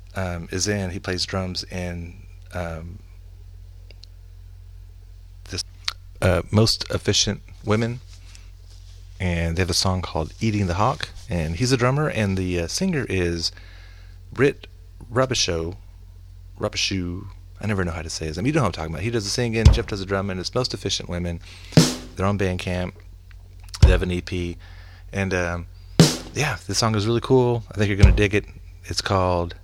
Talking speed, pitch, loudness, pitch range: 170 wpm, 90 Hz, -23 LUFS, 90-100 Hz